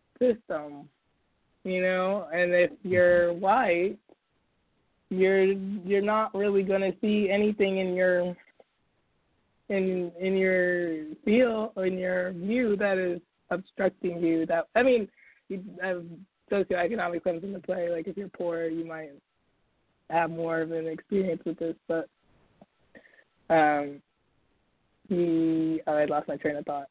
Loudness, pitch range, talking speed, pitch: -27 LUFS, 165-195 Hz, 135 wpm, 180 Hz